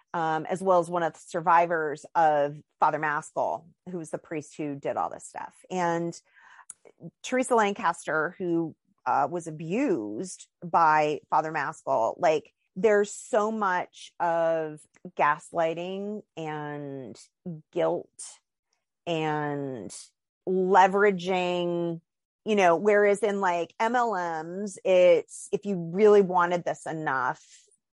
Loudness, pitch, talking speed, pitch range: -26 LUFS, 175 Hz, 115 wpm, 160-195 Hz